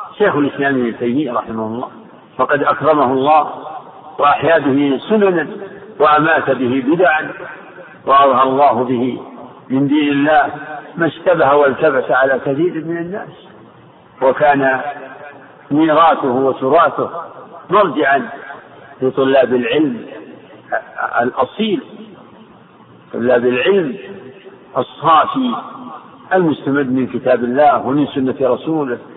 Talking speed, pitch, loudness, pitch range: 90 wpm, 140 Hz, -14 LUFS, 130-155 Hz